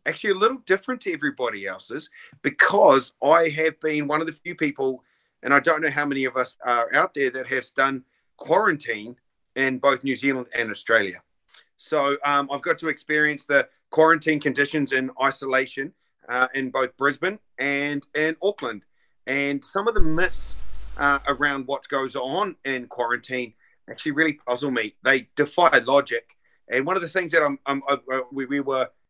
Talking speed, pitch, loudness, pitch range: 180 wpm, 140 Hz, -23 LUFS, 130-155 Hz